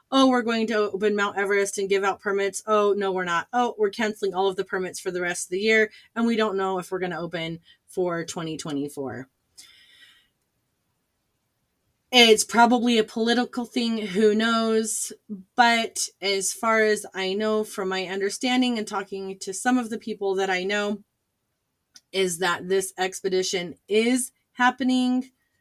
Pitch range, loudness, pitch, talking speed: 190-225 Hz, -24 LUFS, 205 Hz, 165 wpm